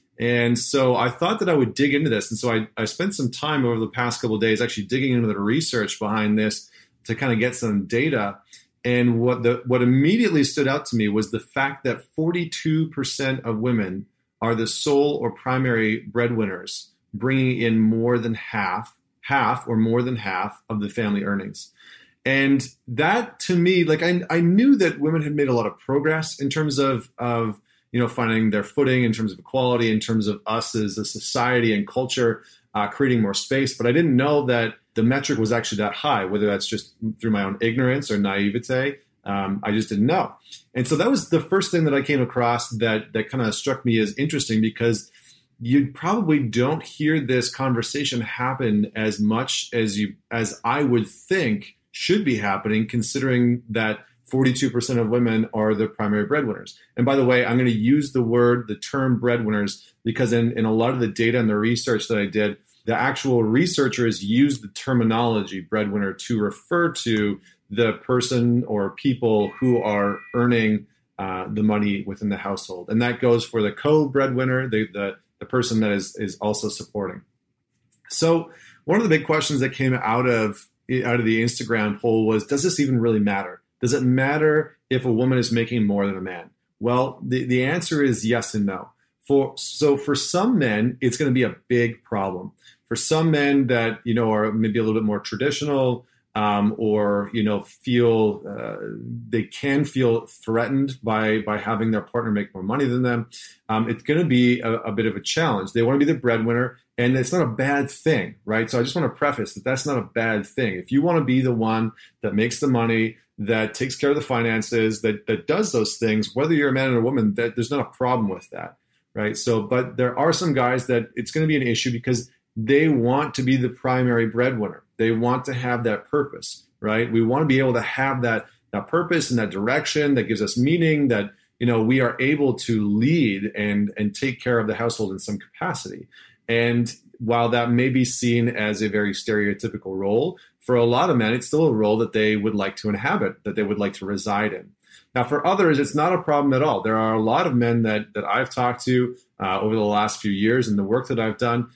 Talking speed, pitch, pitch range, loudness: 215 wpm, 120 Hz, 110-135 Hz, -22 LUFS